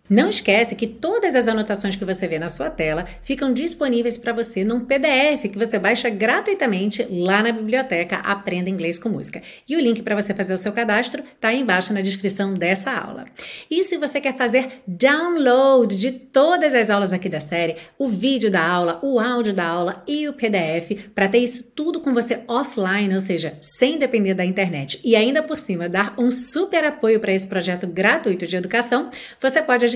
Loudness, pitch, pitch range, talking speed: -20 LUFS, 225 Hz, 190-260 Hz, 195 wpm